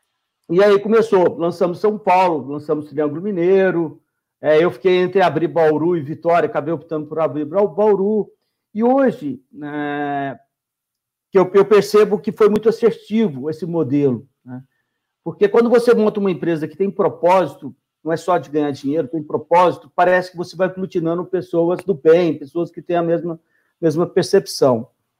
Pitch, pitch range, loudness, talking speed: 170 Hz, 155-195 Hz, -17 LUFS, 155 wpm